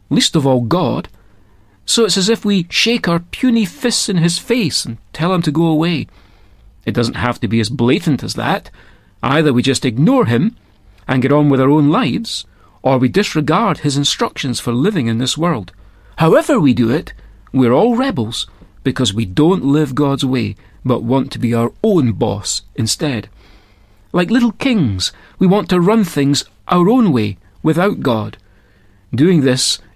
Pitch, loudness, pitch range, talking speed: 130 Hz, -15 LUFS, 105-170 Hz, 180 wpm